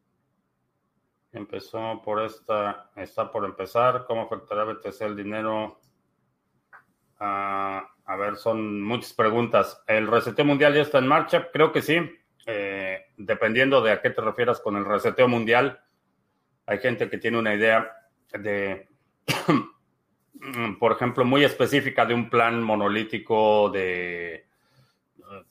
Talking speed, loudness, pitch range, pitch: 125 wpm, -24 LUFS, 100-120 Hz, 110 Hz